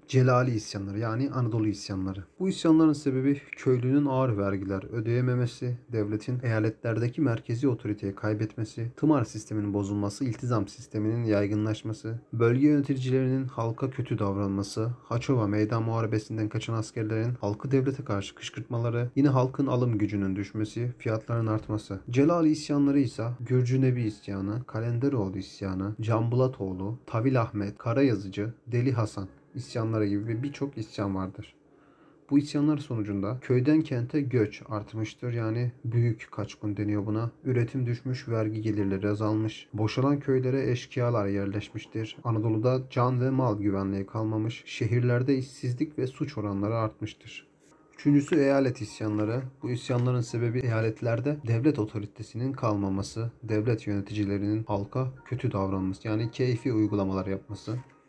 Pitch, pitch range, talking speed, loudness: 115 Hz, 105-130 Hz, 120 wpm, -29 LUFS